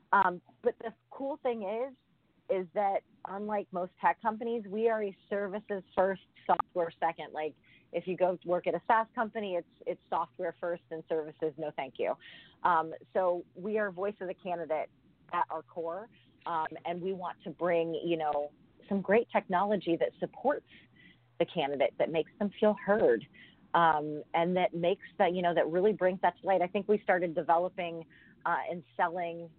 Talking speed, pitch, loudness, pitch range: 185 wpm, 180 Hz, -32 LUFS, 165-205 Hz